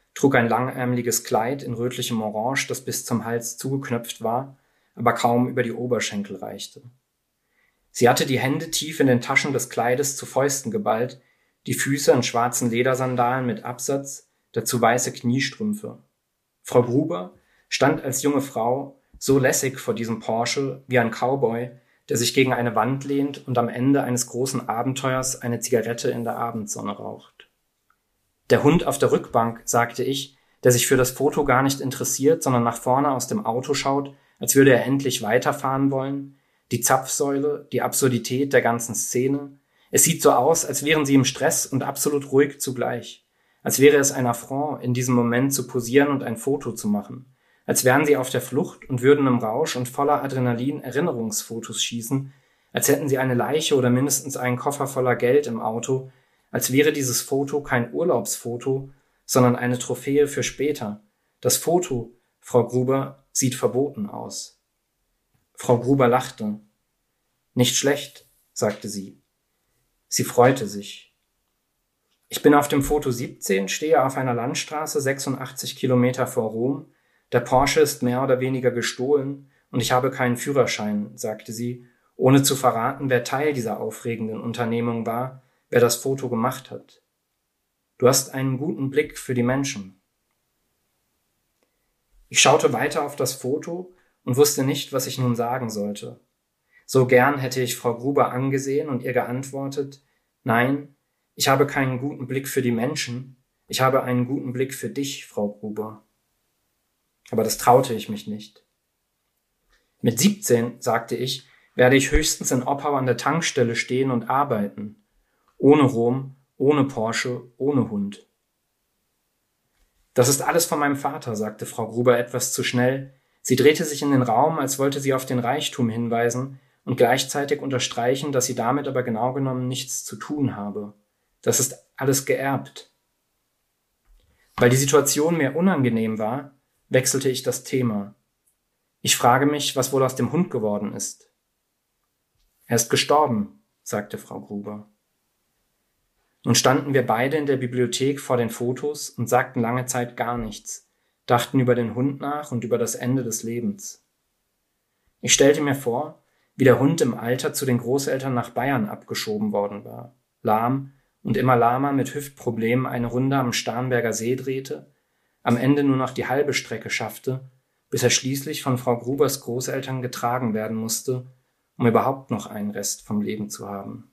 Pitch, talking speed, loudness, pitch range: 130 Hz, 160 wpm, -22 LUFS, 120-140 Hz